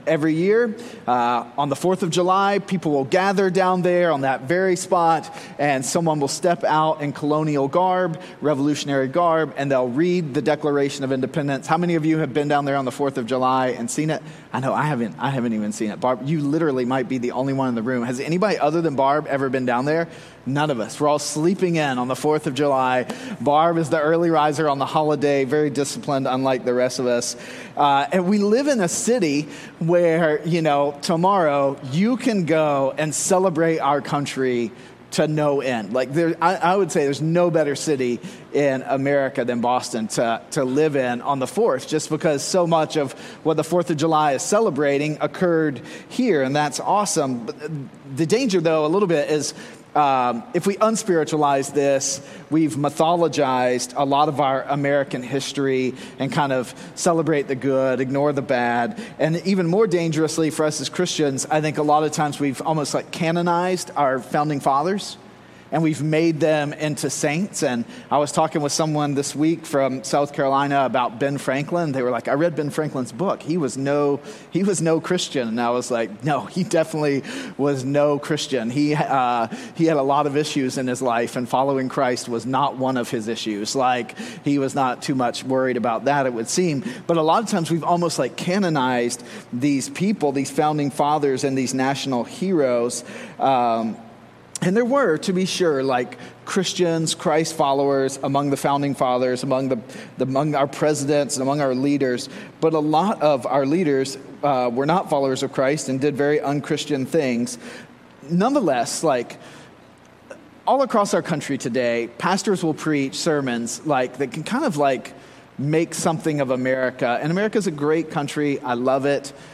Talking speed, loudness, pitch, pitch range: 195 wpm, -21 LUFS, 145 Hz, 135-165 Hz